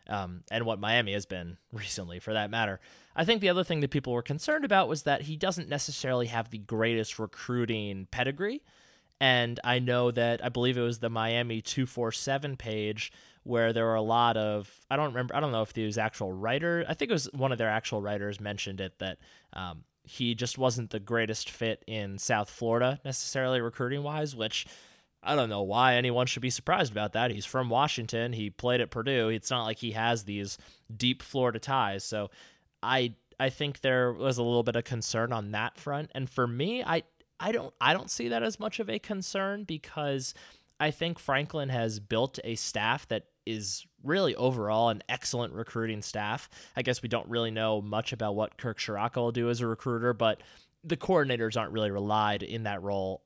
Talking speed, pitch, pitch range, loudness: 205 wpm, 120 Hz, 110-135 Hz, -30 LUFS